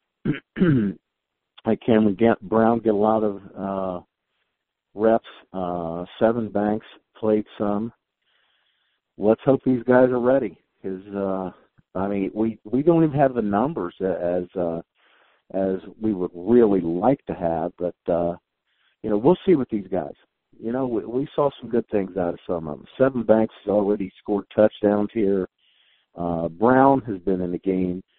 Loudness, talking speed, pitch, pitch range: -22 LUFS, 165 wpm, 105 Hz, 95-115 Hz